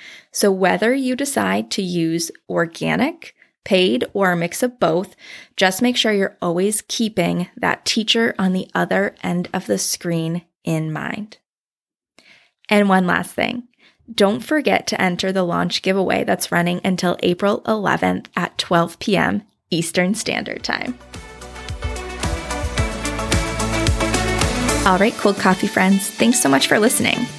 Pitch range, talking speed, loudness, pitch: 170-220 Hz, 135 wpm, -19 LUFS, 190 Hz